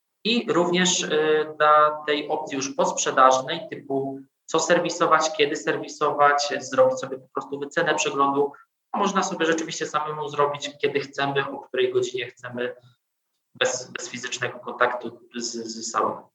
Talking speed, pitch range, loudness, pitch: 130 wpm, 135-165 Hz, -23 LUFS, 150 Hz